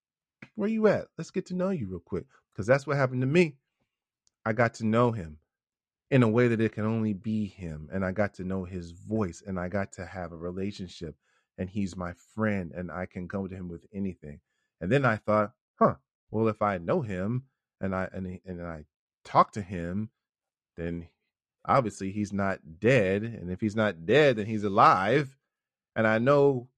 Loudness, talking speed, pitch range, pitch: -28 LUFS, 205 wpm, 90-115 Hz, 100 Hz